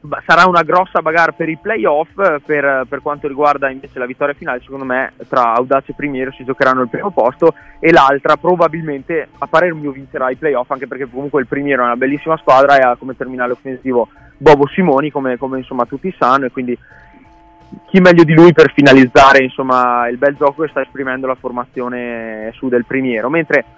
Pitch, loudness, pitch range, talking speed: 140 Hz, -13 LUFS, 130-155 Hz, 190 wpm